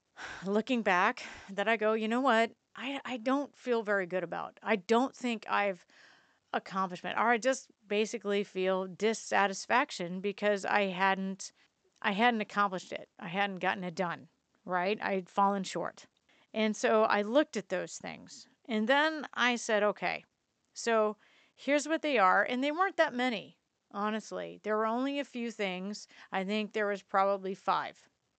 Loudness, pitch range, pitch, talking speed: -32 LUFS, 195-245 Hz, 215 Hz, 165 wpm